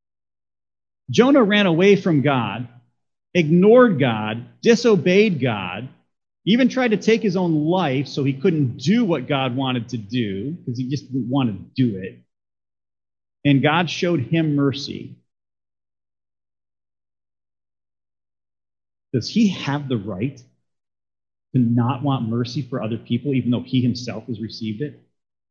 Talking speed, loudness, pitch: 135 wpm, -20 LUFS, 120 Hz